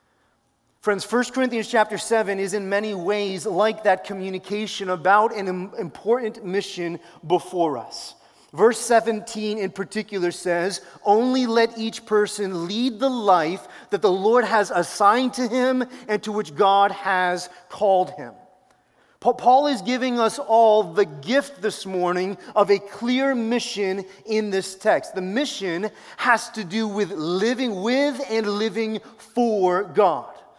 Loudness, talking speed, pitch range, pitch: -22 LUFS, 140 wpm, 190-230 Hz, 210 Hz